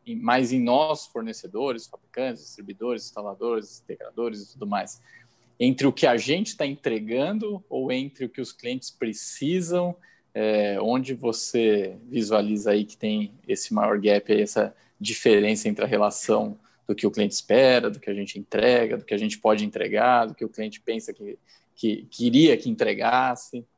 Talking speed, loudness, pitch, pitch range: 170 wpm, -24 LUFS, 115 Hz, 105-135 Hz